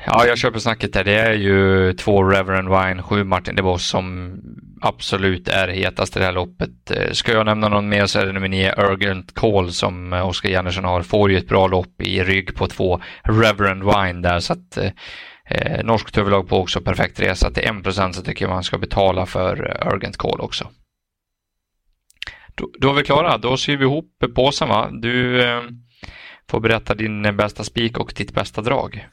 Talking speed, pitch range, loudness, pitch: 190 wpm, 95-115 Hz, -19 LUFS, 100 Hz